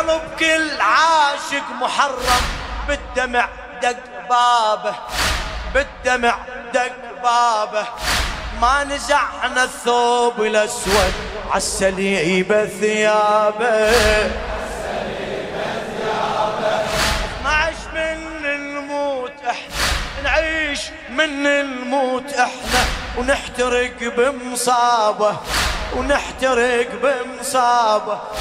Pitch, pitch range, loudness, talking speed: 245 Hz, 215-280 Hz, -18 LUFS, 65 wpm